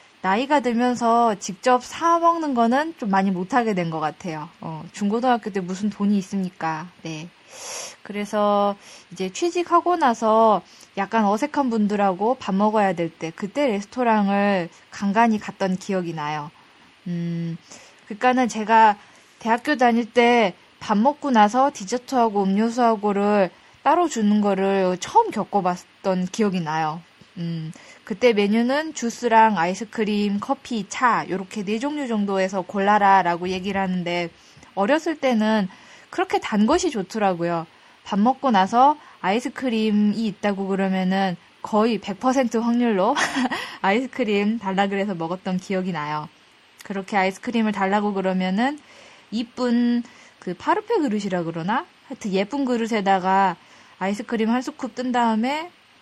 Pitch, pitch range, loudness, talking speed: 210 Hz, 190-245 Hz, -22 LUFS, 295 characters per minute